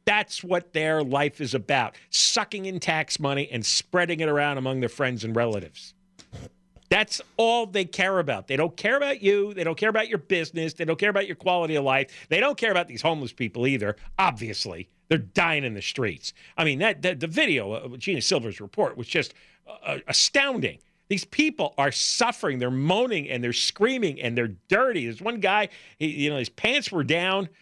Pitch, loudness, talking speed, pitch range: 165 Hz, -25 LUFS, 200 wpm, 135-200 Hz